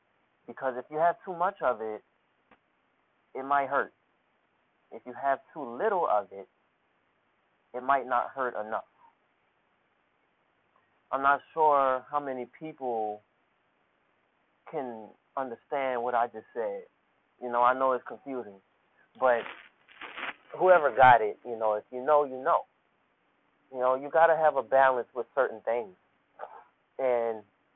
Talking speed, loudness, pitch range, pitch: 140 wpm, -28 LUFS, 120-140 Hz, 130 Hz